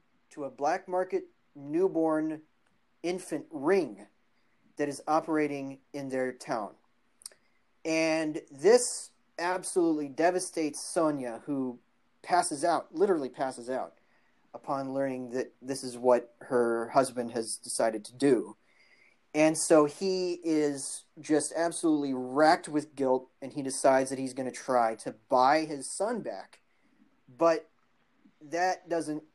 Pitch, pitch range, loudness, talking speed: 150 Hz, 130-170 Hz, -30 LUFS, 125 wpm